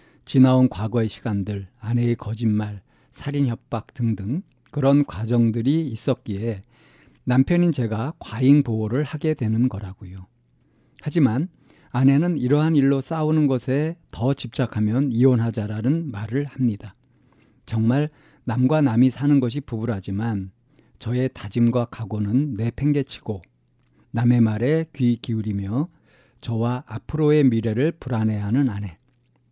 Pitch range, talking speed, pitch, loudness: 110-140 Hz, 270 characters per minute, 125 Hz, -22 LUFS